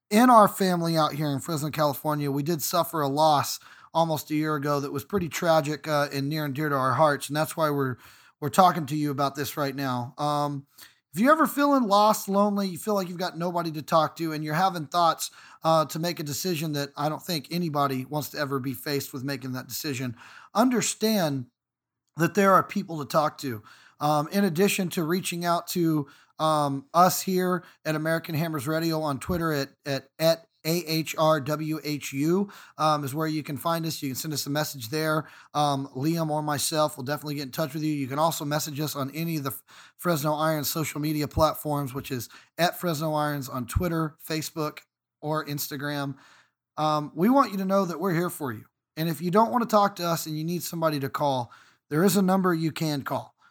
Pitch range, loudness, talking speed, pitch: 145-170 Hz, -26 LUFS, 215 wpm, 155 Hz